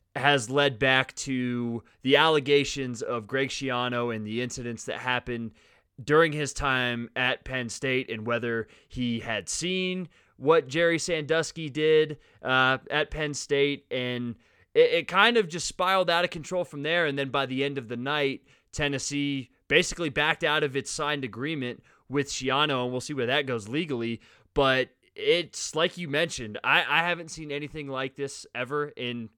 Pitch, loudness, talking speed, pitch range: 140 Hz, -27 LUFS, 170 wpm, 125-155 Hz